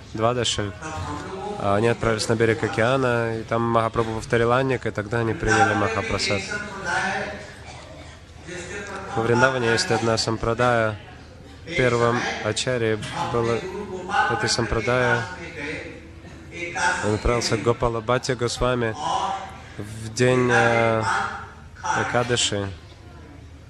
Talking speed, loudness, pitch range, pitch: 90 wpm, -23 LUFS, 110-120 Hz, 115 Hz